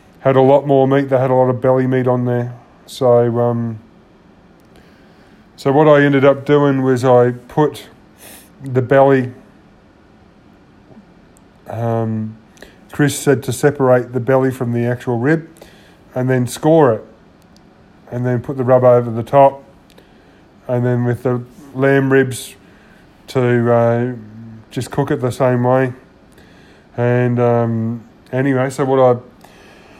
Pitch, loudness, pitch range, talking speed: 125 Hz, -15 LUFS, 120-135 Hz, 140 wpm